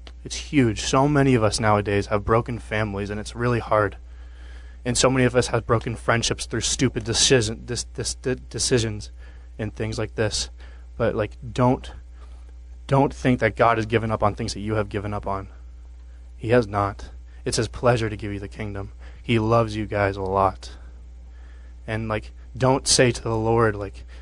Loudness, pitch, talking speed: -23 LUFS, 105 Hz, 180 wpm